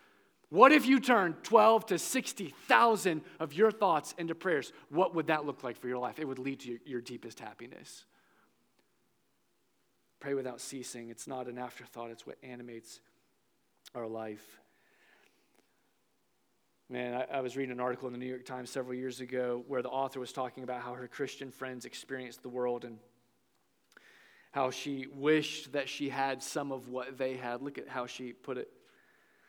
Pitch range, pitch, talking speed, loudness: 125-145 Hz, 130 Hz, 175 wpm, -33 LUFS